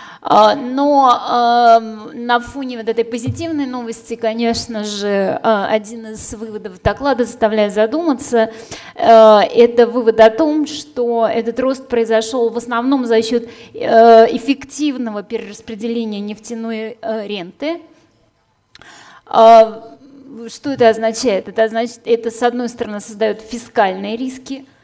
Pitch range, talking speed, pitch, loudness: 225-245 Hz, 105 wpm, 230 Hz, -15 LUFS